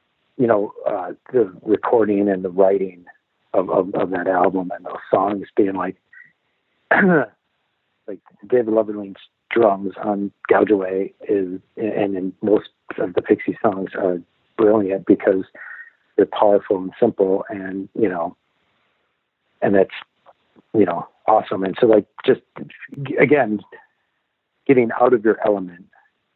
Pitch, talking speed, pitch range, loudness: 100 Hz, 130 wpm, 95-105 Hz, -19 LUFS